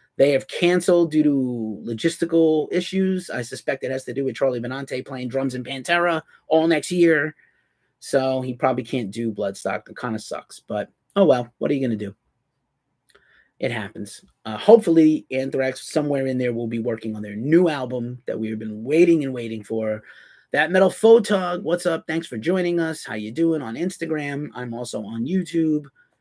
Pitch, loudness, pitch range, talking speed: 140 Hz, -22 LUFS, 125-165 Hz, 190 wpm